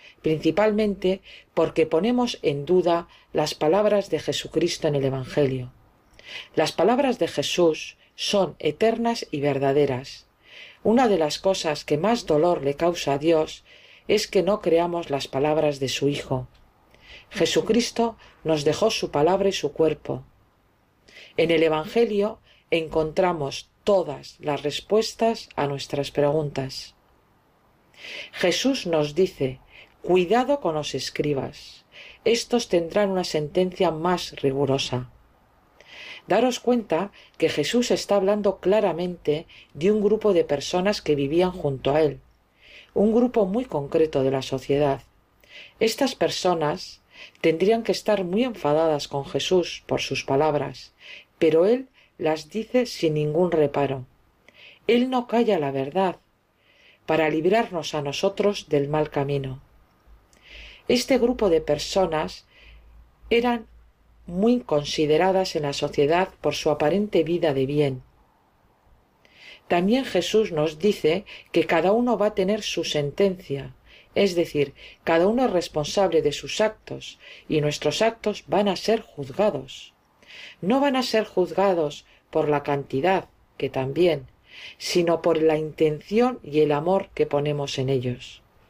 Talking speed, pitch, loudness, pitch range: 130 wpm, 160 Hz, -23 LUFS, 145-200 Hz